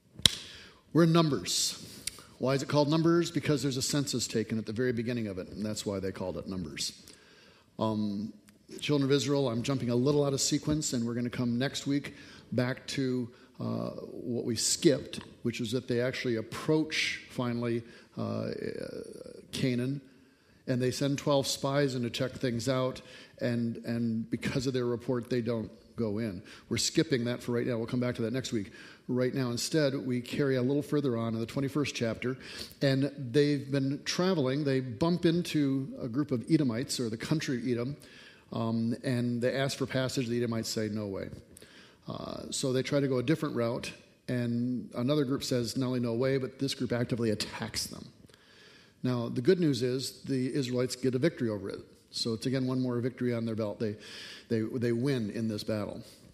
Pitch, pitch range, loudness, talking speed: 125 Hz, 115-140 Hz, -31 LUFS, 195 wpm